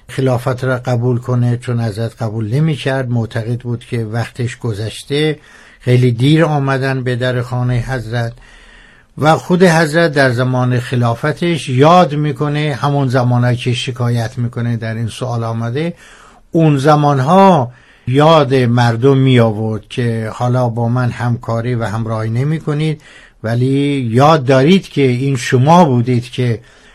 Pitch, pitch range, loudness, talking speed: 125 Hz, 120-145 Hz, -14 LUFS, 135 wpm